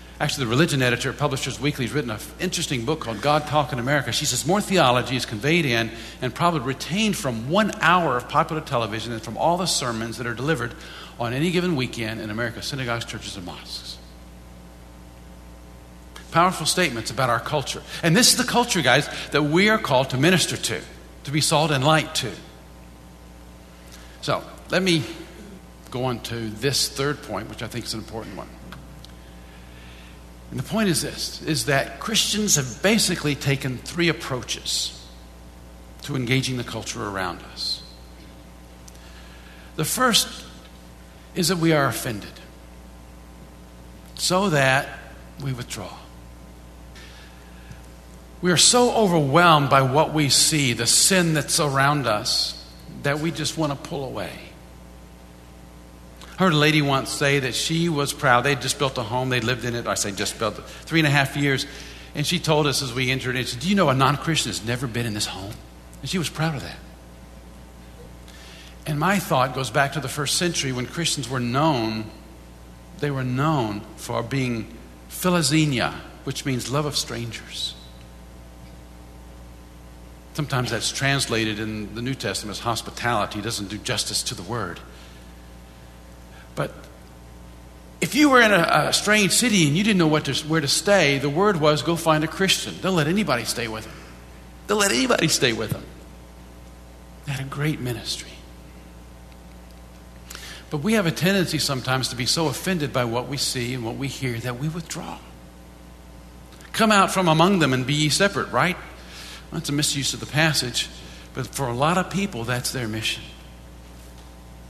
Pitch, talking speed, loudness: 120 Hz, 170 wpm, -22 LUFS